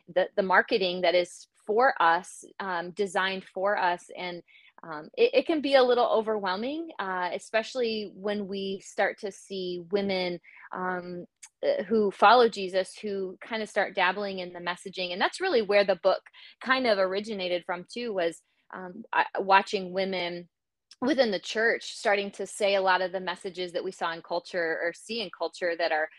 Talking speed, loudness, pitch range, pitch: 175 wpm, -27 LUFS, 180-215 Hz, 190 Hz